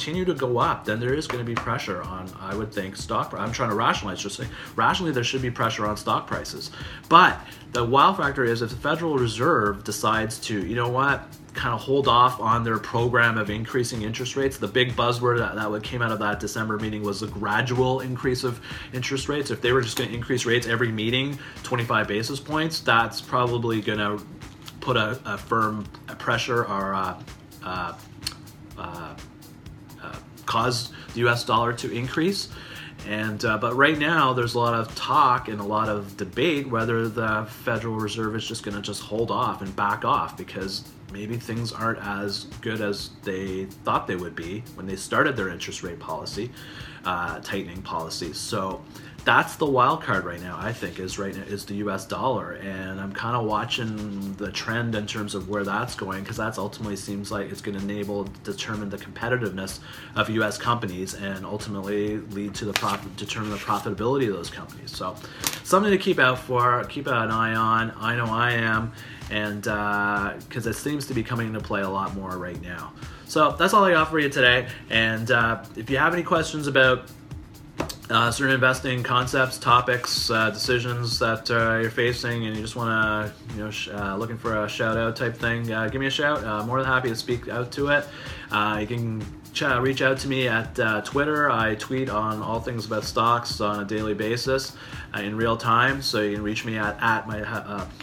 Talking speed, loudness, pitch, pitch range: 205 wpm, -25 LUFS, 115 Hz, 105-125 Hz